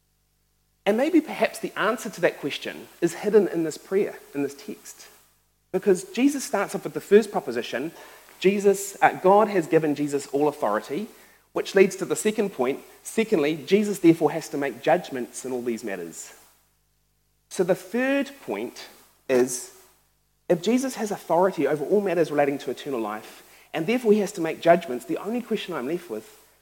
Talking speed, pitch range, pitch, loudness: 175 wpm, 145-205 Hz, 180 Hz, -24 LUFS